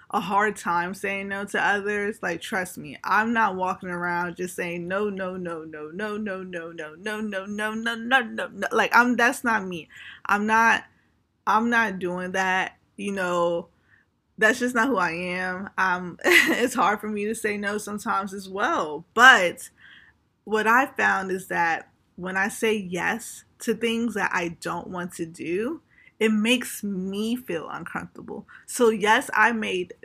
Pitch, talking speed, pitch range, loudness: 200 Hz, 175 wpm, 185-220 Hz, -24 LUFS